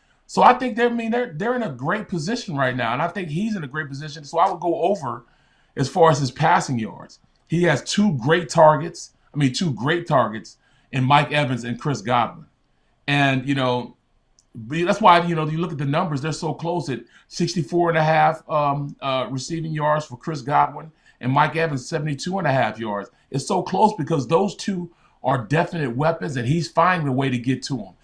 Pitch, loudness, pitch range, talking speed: 155 Hz, -21 LUFS, 135-170 Hz, 205 wpm